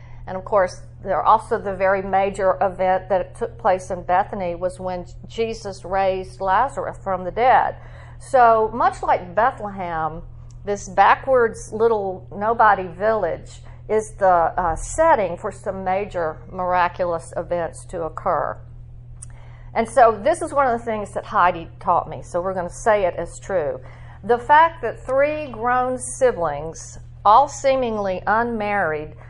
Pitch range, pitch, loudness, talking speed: 175-230 Hz, 195 Hz, -20 LUFS, 145 wpm